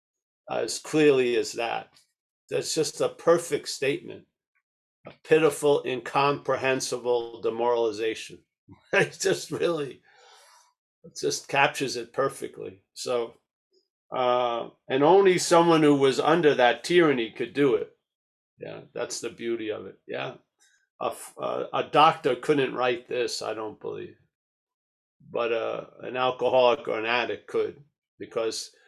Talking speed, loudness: 125 wpm, -25 LUFS